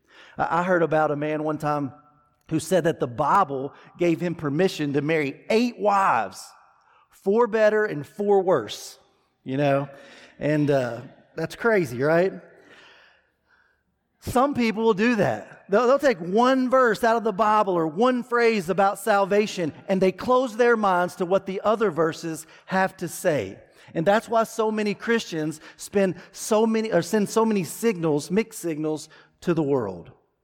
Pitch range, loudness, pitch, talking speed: 155-220 Hz, -23 LUFS, 190 Hz, 160 wpm